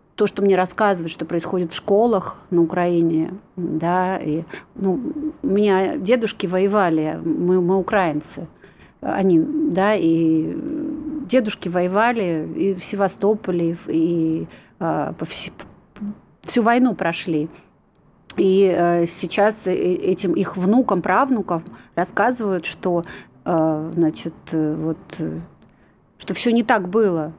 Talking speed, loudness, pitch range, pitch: 110 wpm, -20 LUFS, 165-210 Hz, 185 Hz